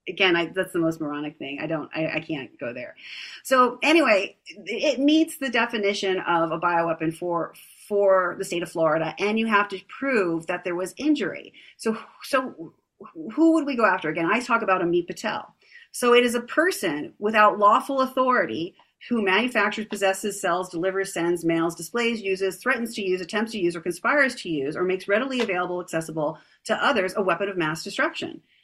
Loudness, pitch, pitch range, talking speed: -24 LUFS, 195 Hz, 175-240 Hz, 190 wpm